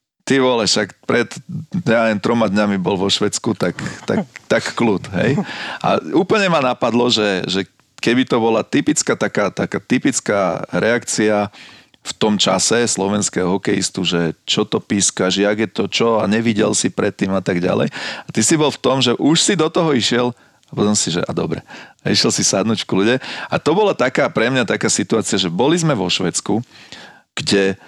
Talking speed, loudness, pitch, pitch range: 190 wpm, -17 LUFS, 110 Hz, 100-125 Hz